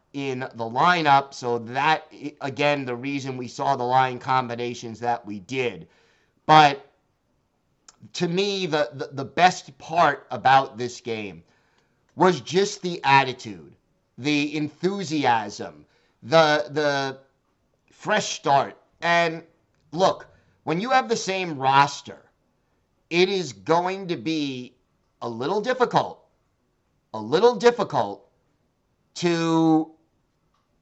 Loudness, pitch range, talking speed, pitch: -23 LUFS, 125-170 Hz, 110 wpm, 145 Hz